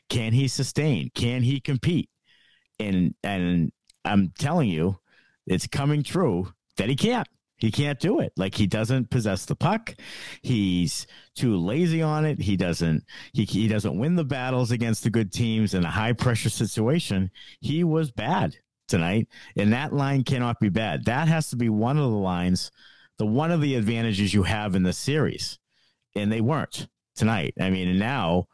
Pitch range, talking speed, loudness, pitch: 100-140 Hz, 180 wpm, -25 LUFS, 115 Hz